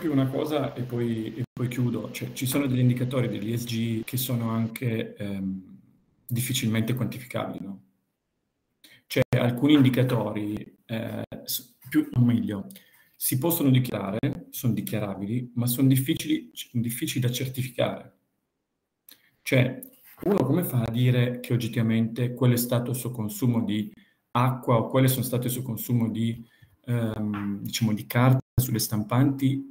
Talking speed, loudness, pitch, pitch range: 140 wpm, -26 LUFS, 120 Hz, 115-130 Hz